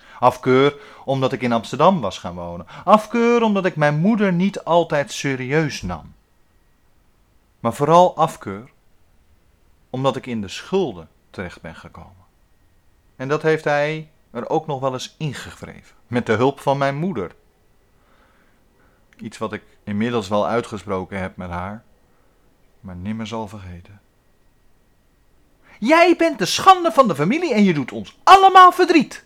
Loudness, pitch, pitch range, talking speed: -18 LUFS, 125 Hz, 95-160 Hz, 145 wpm